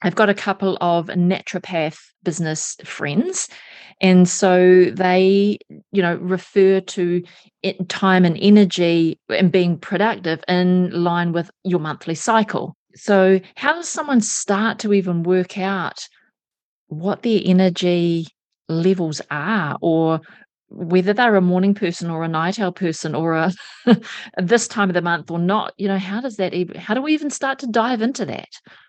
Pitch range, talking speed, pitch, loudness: 175-205 Hz, 160 wpm, 185 Hz, -19 LUFS